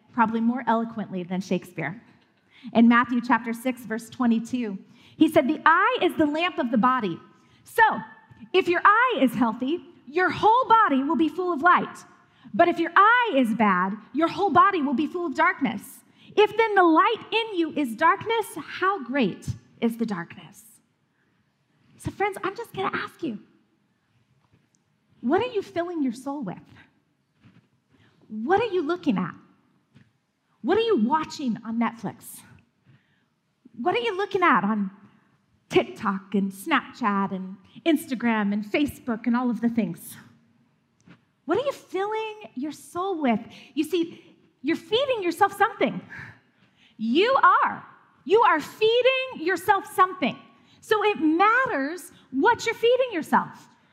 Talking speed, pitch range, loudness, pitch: 150 wpm, 225-375 Hz, -23 LUFS, 295 Hz